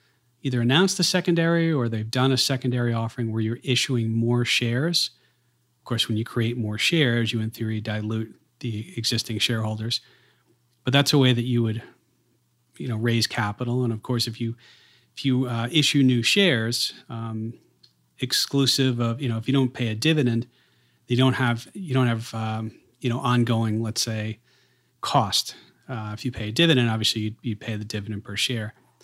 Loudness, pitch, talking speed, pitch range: -24 LUFS, 120 Hz, 185 wpm, 115-130 Hz